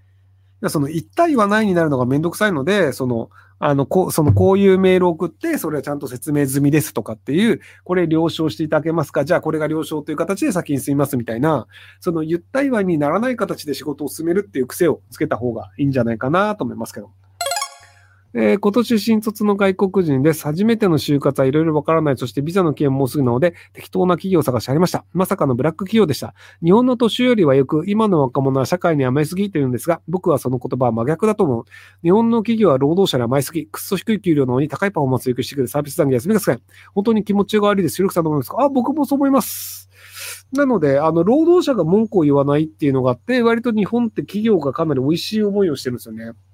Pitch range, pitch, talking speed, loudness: 130-195 Hz, 155 Hz, 500 characters per minute, -18 LUFS